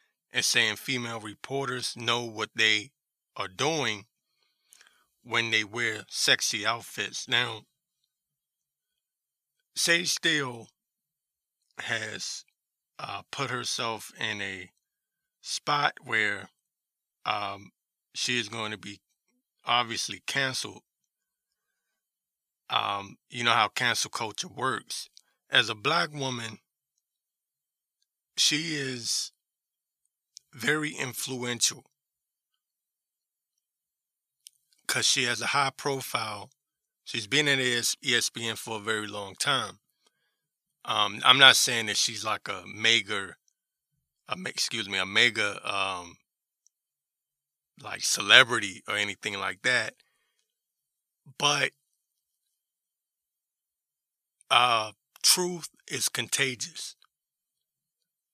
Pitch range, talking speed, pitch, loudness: 115-150 Hz, 90 wpm, 130 Hz, -26 LUFS